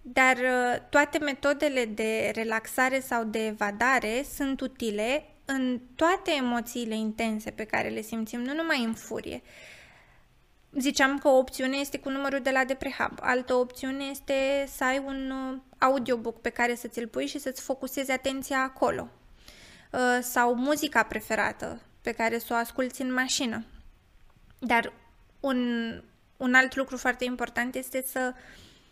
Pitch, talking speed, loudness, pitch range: 255 Hz, 140 wpm, -28 LUFS, 235-270 Hz